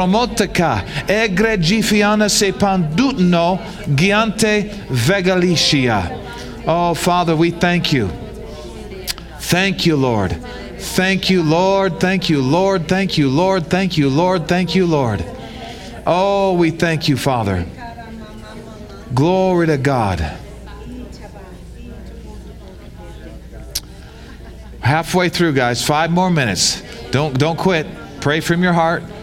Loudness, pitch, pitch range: -16 LUFS, 170 Hz, 140-190 Hz